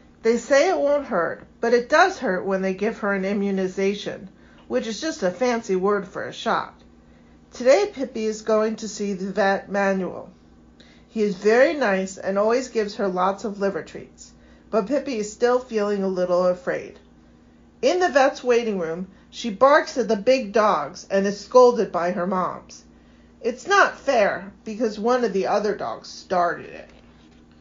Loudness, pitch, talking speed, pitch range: -22 LUFS, 205 Hz, 175 wpm, 190-240 Hz